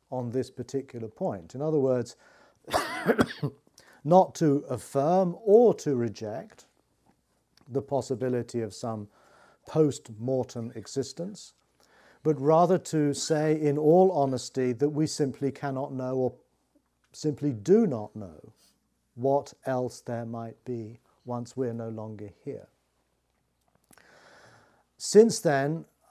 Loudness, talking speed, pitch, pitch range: -27 LUFS, 110 wpm, 135 Hz, 120-155 Hz